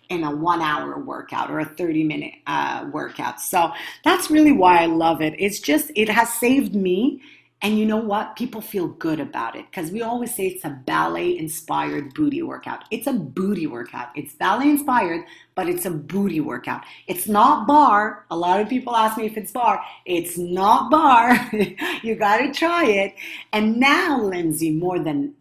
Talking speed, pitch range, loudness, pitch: 190 wpm, 175-275 Hz, -20 LUFS, 210 Hz